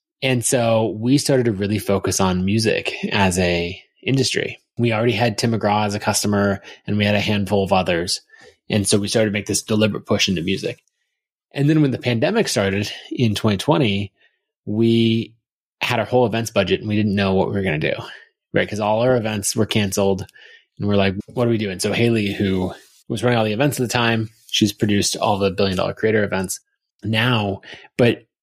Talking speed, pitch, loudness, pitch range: 205 wpm, 110 Hz, -19 LUFS, 100-120 Hz